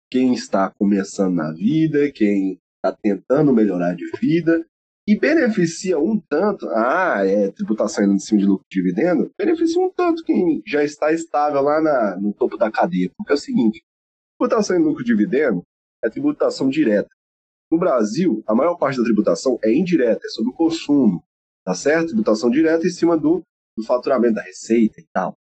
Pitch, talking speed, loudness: 160 Hz, 175 wpm, -19 LUFS